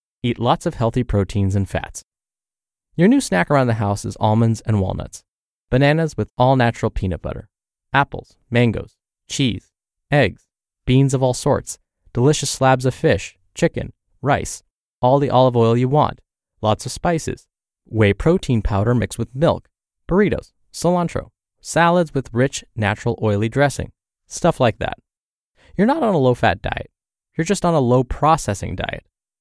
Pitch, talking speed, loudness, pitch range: 120 Hz, 155 wpm, -19 LUFS, 105-140 Hz